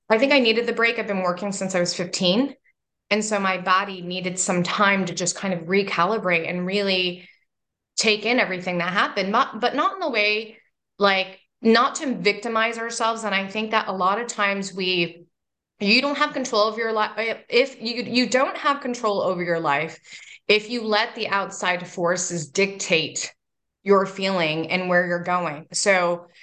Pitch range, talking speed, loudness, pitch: 180-225 Hz, 185 wpm, -22 LUFS, 195 Hz